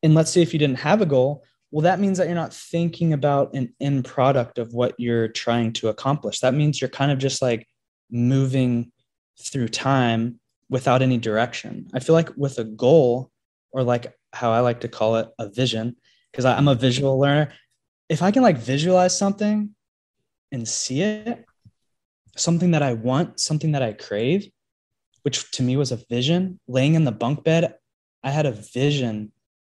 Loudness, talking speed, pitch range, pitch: -22 LUFS, 185 wpm, 120-155 Hz, 130 Hz